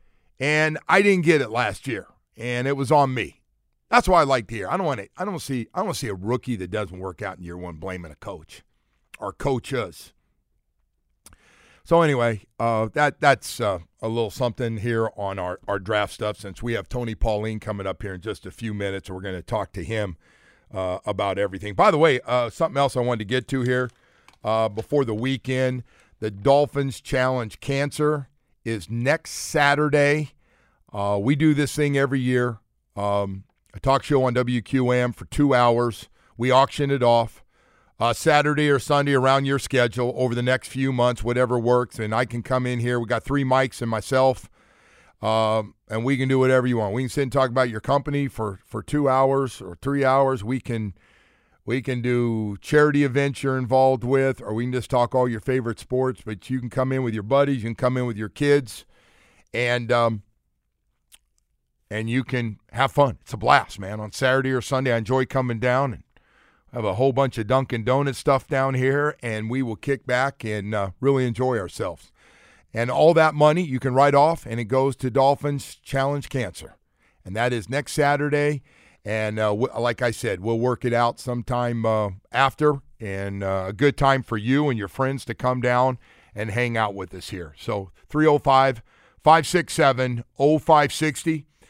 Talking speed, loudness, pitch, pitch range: 200 wpm, -23 LUFS, 125 Hz, 110-135 Hz